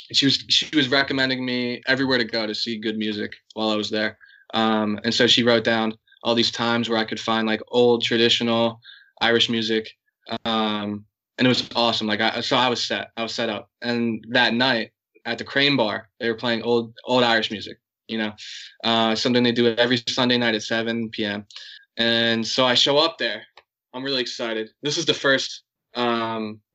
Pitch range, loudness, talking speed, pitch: 110-120 Hz, -21 LUFS, 200 wpm, 115 Hz